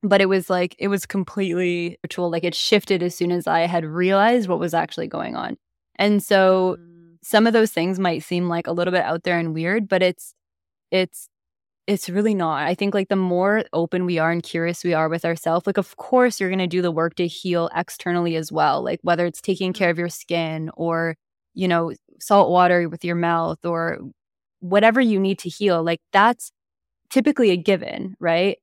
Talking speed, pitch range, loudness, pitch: 210 wpm, 170-195 Hz, -21 LUFS, 175 Hz